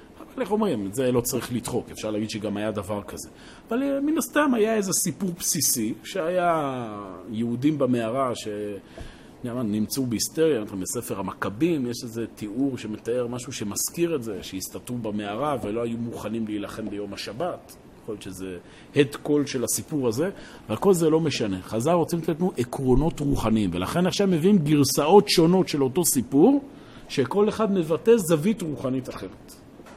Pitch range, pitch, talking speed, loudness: 110-175 Hz, 135 Hz, 155 wpm, -24 LUFS